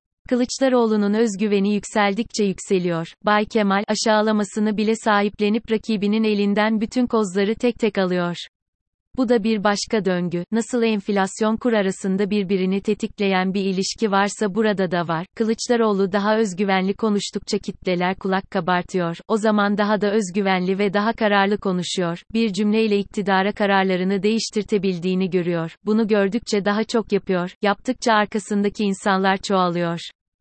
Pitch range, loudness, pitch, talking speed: 190-220 Hz, -21 LUFS, 205 Hz, 125 wpm